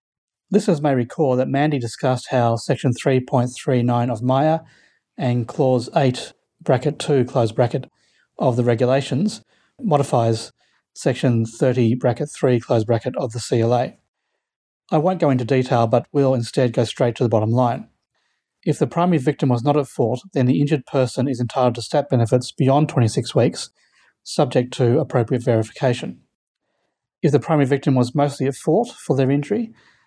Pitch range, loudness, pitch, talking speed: 120-145 Hz, -20 LUFS, 130 Hz, 160 wpm